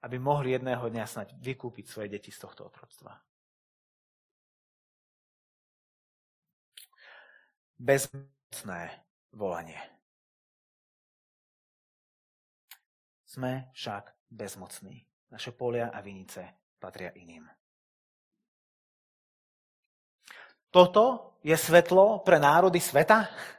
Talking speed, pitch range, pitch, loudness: 70 wpm, 115-170 Hz, 130 Hz, -25 LUFS